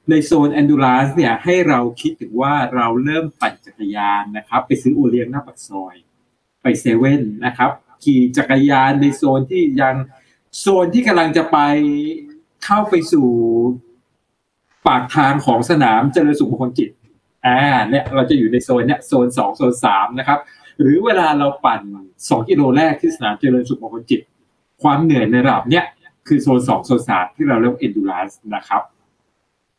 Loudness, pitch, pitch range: -15 LUFS, 135 Hz, 125-160 Hz